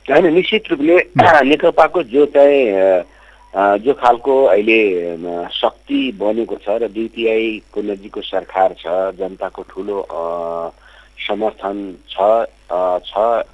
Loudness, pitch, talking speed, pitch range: -15 LUFS, 105 Hz, 95 wpm, 95-140 Hz